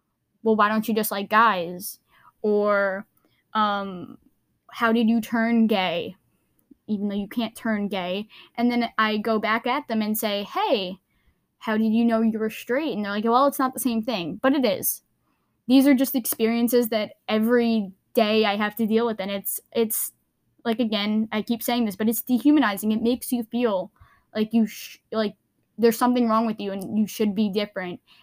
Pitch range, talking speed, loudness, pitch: 210-235 Hz, 195 wpm, -23 LUFS, 220 Hz